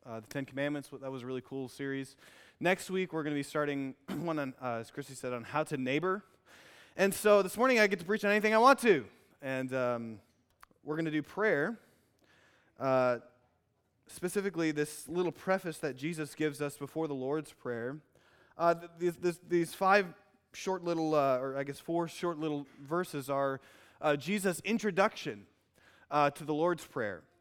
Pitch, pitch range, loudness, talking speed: 150 Hz, 135-175 Hz, -33 LUFS, 185 wpm